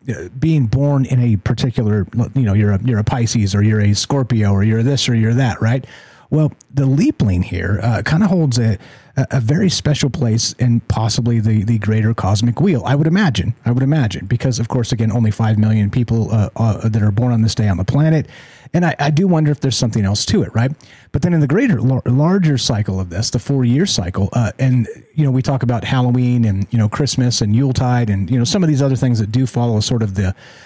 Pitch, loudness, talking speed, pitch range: 120 Hz, -16 LUFS, 235 wpm, 110-135 Hz